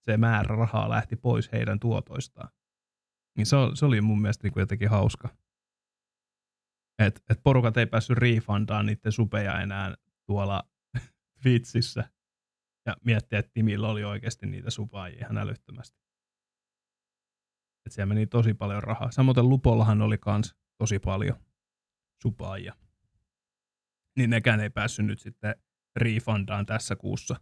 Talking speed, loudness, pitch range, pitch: 130 wpm, -27 LUFS, 100-115 Hz, 105 Hz